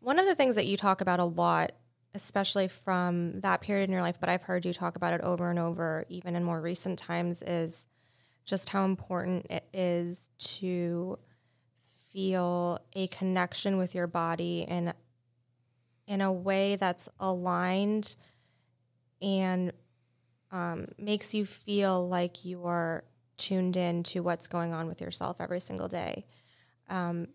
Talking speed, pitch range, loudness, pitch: 155 wpm, 170-190 Hz, -32 LUFS, 180 Hz